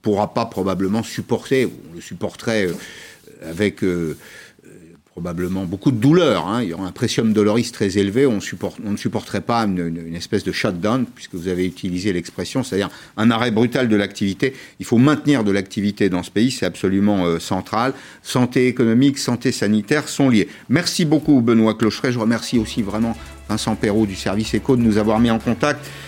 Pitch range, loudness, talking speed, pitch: 95-120 Hz, -19 LUFS, 190 wpm, 110 Hz